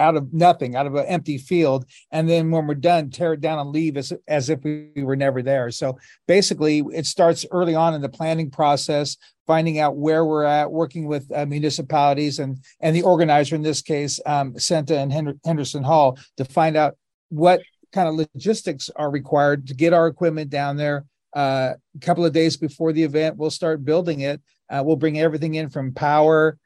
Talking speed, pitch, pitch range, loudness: 205 wpm, 155 Hz, 145-160 Hz, -21 LUFS